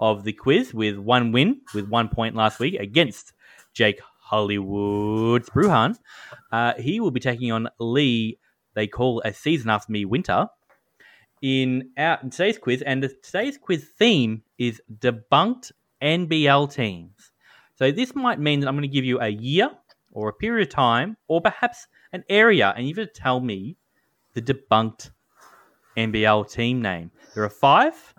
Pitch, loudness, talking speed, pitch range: 125 Hz, -22 LUFS, 165 wpm, 110-145 Hz